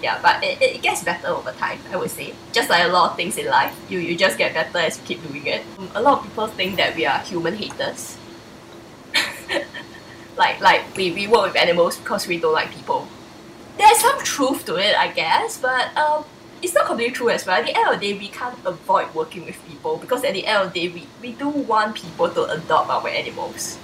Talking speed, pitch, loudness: 235 wpm, 270 Hz, -20 LUFS